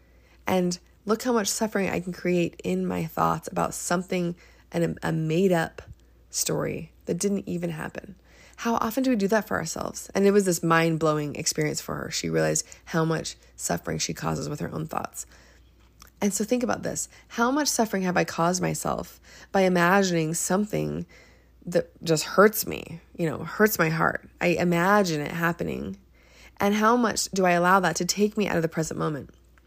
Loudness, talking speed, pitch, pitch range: -25 LUFS, 190 wpm, 170 Hz, 150-200 Hz